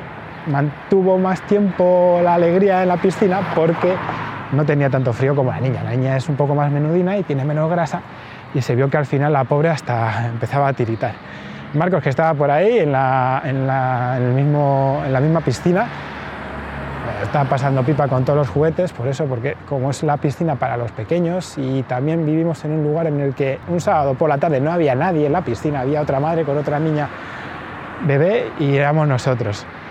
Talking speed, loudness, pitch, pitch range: 205 wpm, -18 LUFS, 145 Hz, 130-160 Hz